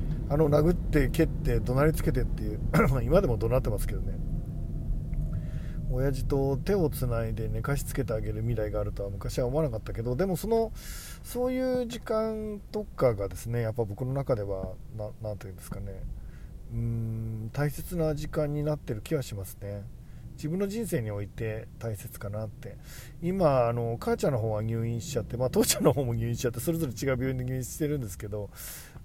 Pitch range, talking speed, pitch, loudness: 110-150 Hz, 385 characters per minute, 125 Hz, -30 LUFS